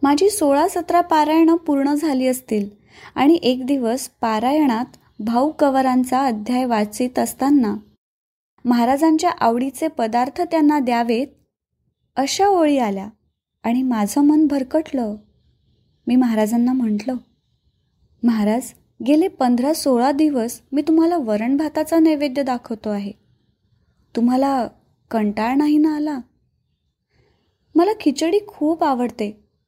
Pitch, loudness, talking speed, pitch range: 265 Hz, -19 LUFS, 105 wpm, 235-305 Hz